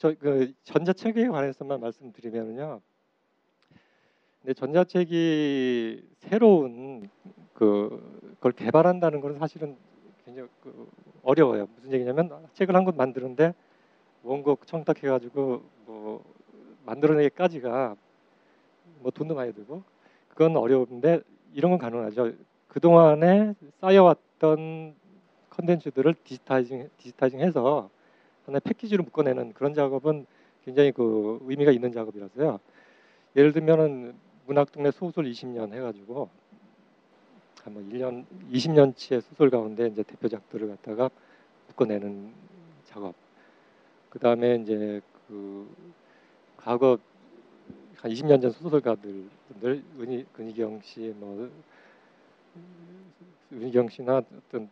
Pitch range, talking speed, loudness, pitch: 120-160 Hz, 240 characters per minute, -25 LUFS, 135 Hz